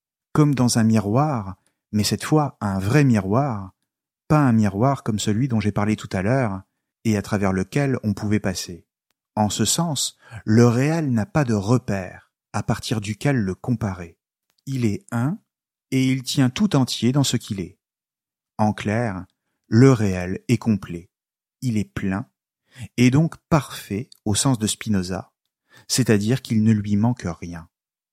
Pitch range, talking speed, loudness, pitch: 100-130 Hz, 160 wpm, -21 LUFS, 110 Hz